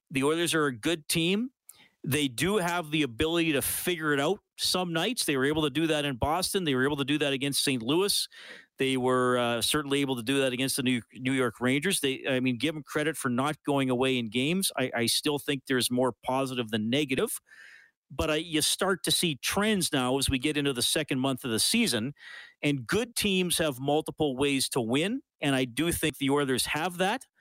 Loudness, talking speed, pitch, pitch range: -28 LUFS, 225 wpm, 145 Hz, 130-160 Hz